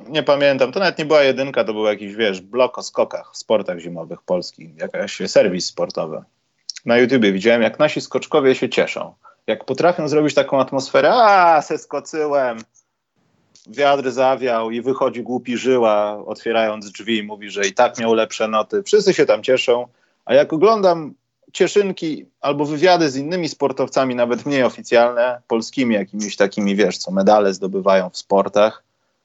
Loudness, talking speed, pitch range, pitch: -18 LUFS, 155 wpm, 110-150 Hz, 125 Hz